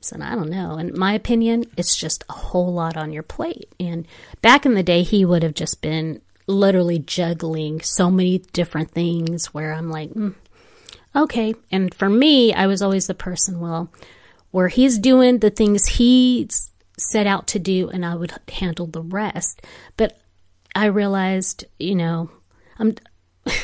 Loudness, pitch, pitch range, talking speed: -19 LUFS, 185 Hz, 165-215 Hz, 170 wpm